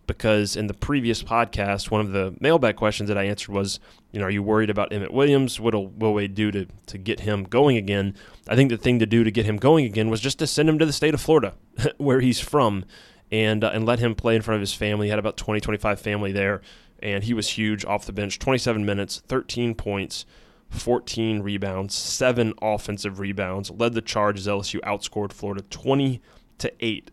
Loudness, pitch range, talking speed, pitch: -23 LUFS, 100-120 Hz, 220 wpm, 105 Hz